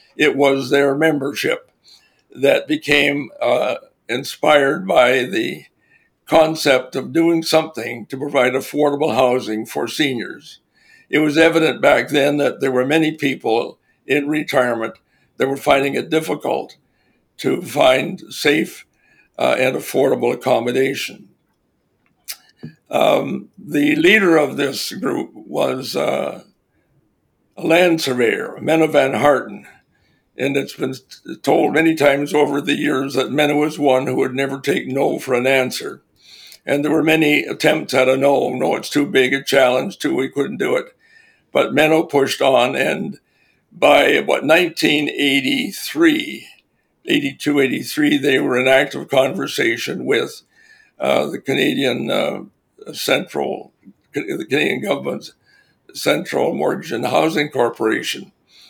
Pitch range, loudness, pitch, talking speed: 135-160 Hz, -17 LUFS, 145 Hz, 130 wpm